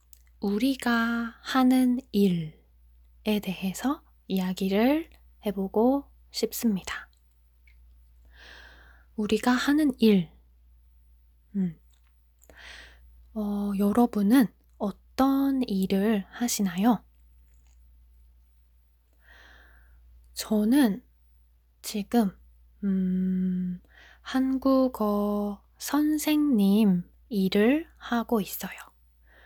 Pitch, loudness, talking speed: 195 Hz, -26 LUFS, 120 characters per minute